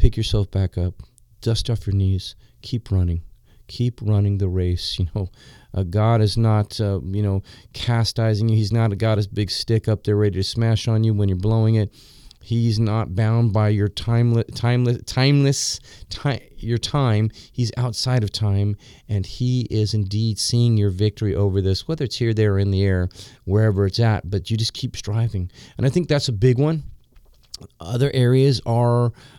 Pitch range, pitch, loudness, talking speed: 100-120 Hz, 110 Hz, -21 LUFS, 190 wpm